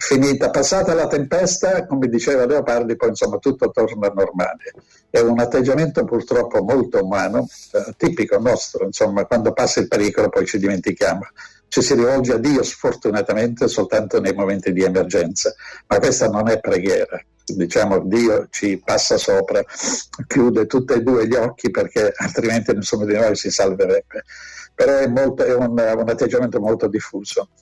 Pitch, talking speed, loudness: 365 Hz, 155 wpm, -18 LUFS